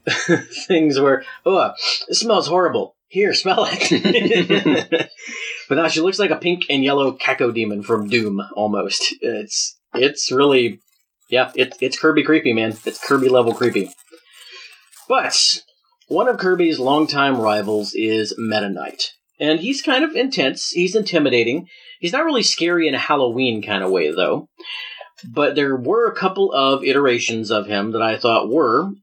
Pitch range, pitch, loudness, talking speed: 115-180 Hz, 140 Hz, -18 LUFS, 155 wpm